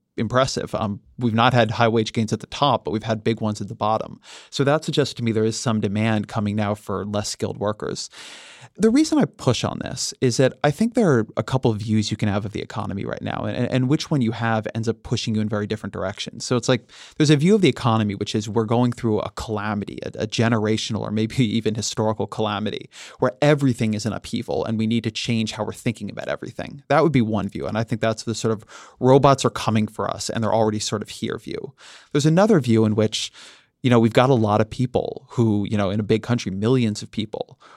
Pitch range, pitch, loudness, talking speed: 110-125 Hz, 110 Hz, -22 LUFS, 250 wpm